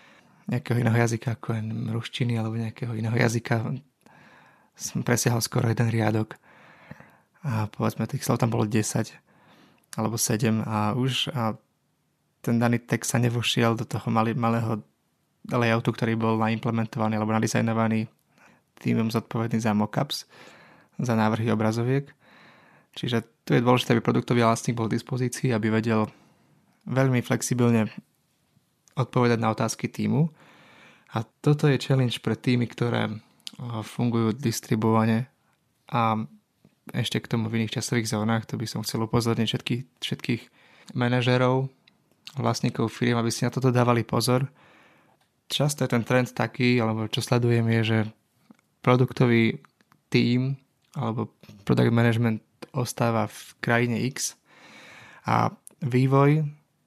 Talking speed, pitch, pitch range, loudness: 125 wpm, 115 Hz, 110-125 Hz, -25 LUFS